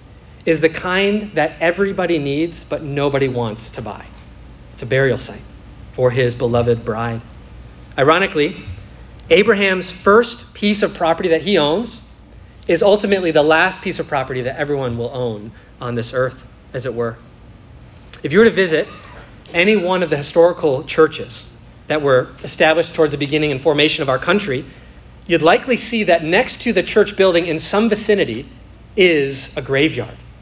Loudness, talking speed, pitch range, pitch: -16 LUFS, 160 wpm, 125-185 Hz, 155 Hz